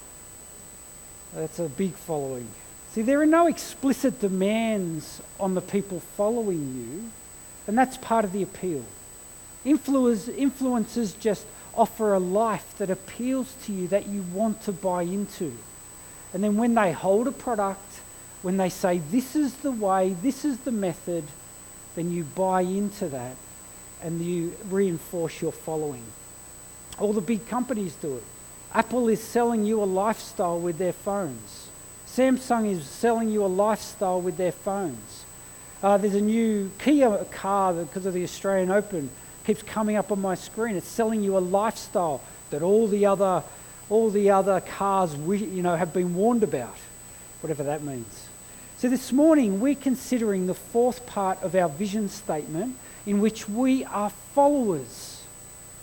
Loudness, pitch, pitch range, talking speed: -26 LUFS, 195 Hz, 175-225 Hz, 155 wpm